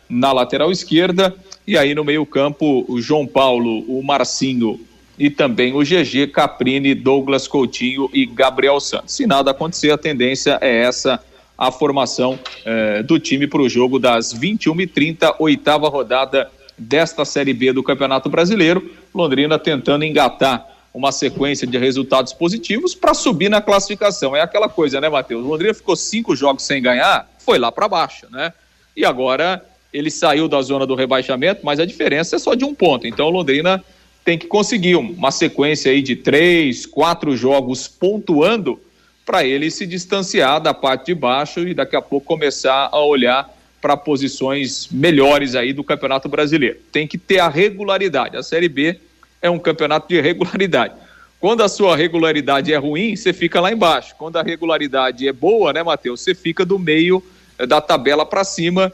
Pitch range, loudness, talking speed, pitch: 135-175 Hz, -16 LUFS, 170 wpm, 150 Hz